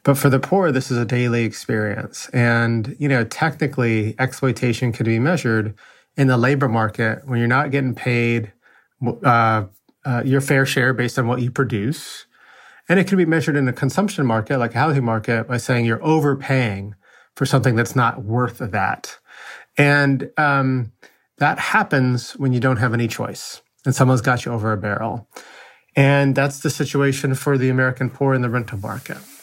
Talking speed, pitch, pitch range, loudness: 180 wpm, 130 Hz, 115-140 Hz, -19 LUFS